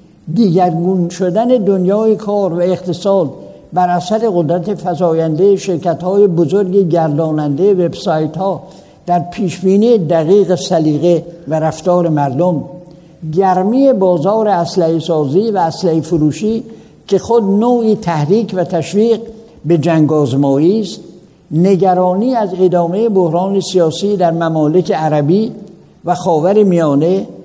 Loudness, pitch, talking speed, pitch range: -13 LUFS, 180 Hz, 110 wpm, 170-200 Hz